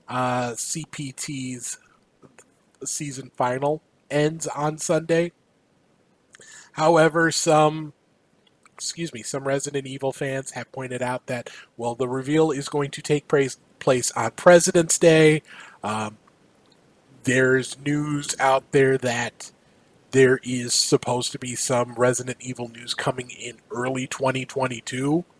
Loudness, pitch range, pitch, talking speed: -23 LUFS, 125-150 Hz, 135 Hz, 120 wpm